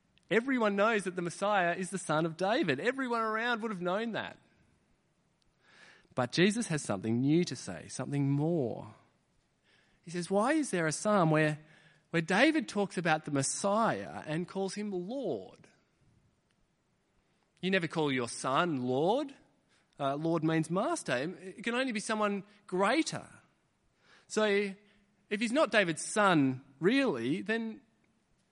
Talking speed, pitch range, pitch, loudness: 140 wpm, 155-215 Hz, 190 Hz, -31 LUFS